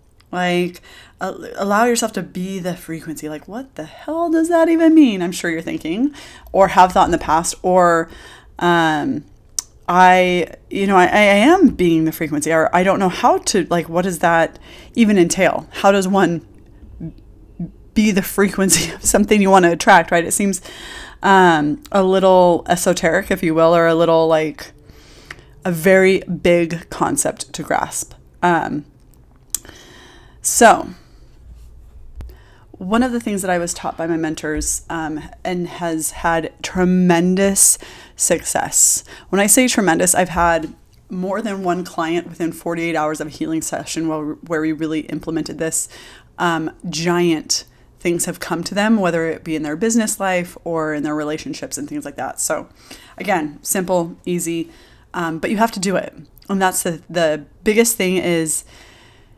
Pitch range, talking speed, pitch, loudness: 160-195 Hz, 165 wpm, 175 Hz, -17 LUFS